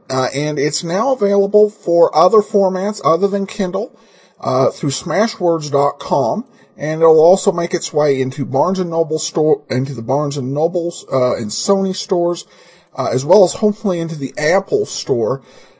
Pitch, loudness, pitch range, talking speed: 170 Hz, -16 LUFS, 145-200 Hz, 155 wpm